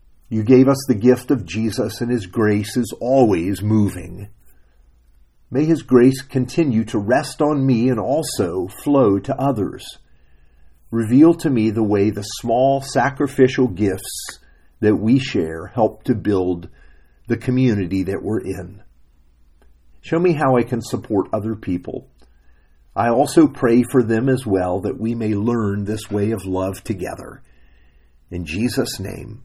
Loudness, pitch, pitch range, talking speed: -19 LUFS, 110 Hz, 90-125 Hz, 150 wpm